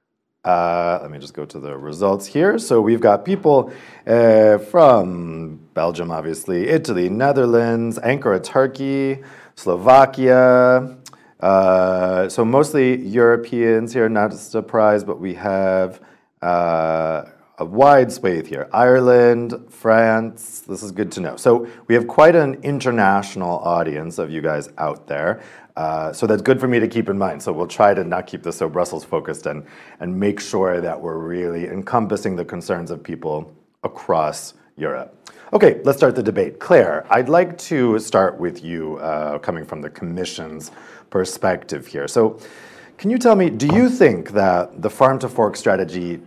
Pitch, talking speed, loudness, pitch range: 110 Hz, 160 wpm, -17 LUFS, 90-125 Hz